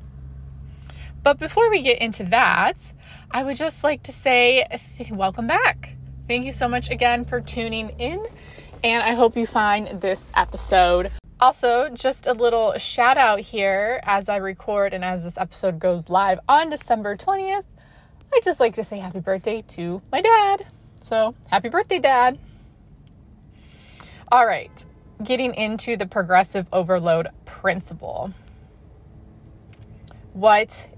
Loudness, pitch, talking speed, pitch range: -20 LUFS, 215 Hz, 140 wpm, 185-245 Hz